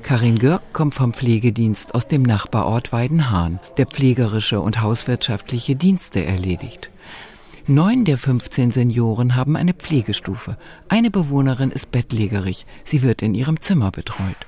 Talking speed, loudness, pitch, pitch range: 135 wpm, -19 LUFS, 120 Hz, 110-140 Hz